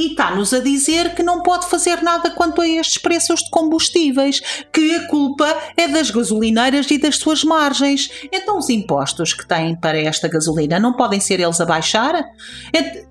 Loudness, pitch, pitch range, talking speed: -16 LUFS, 300 Hz, 225-335 Hz, 185 wpm